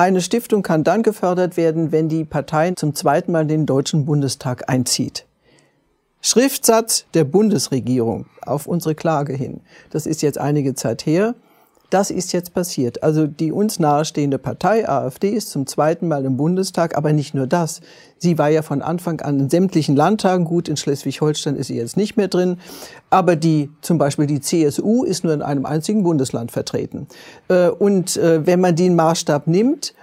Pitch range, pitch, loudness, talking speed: 145-180 Hz, 160 Hz, -18 LUFS, 175 wpm